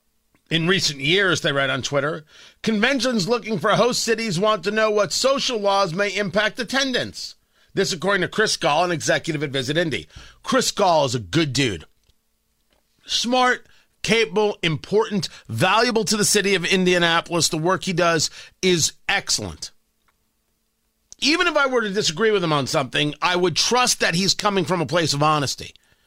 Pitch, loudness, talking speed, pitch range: 190 Hz, -20 LUFS, 170 wpm, 160-215 Hz